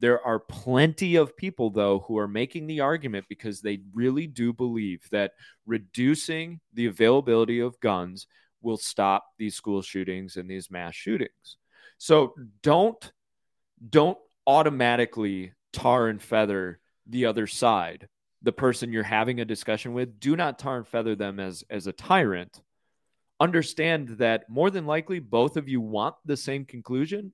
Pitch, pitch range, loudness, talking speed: 120 Hz, 105-145 Hz, -26 LUFS, 155 wpm